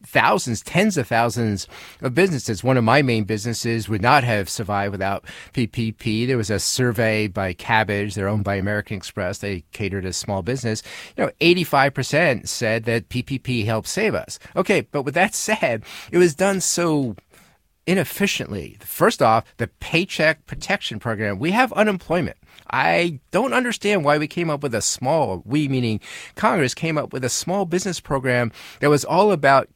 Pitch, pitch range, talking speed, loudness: 125 Hz, 110-165 Hz, 170 wpm, -21 LUFS